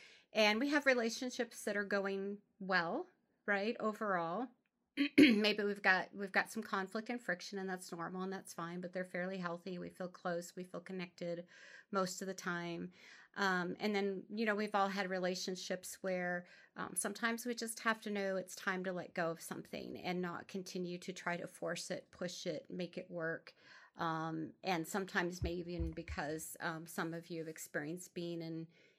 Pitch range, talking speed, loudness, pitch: 175-210 Hz, 185 wpm, -39 LUFS, 185 Hz